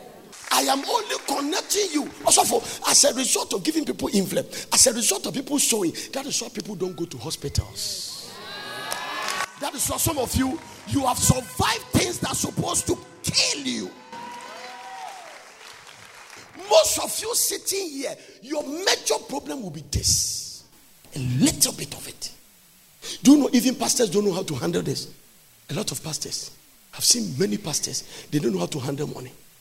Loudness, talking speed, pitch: -23 LUFS, 175 wpm, 245 Hz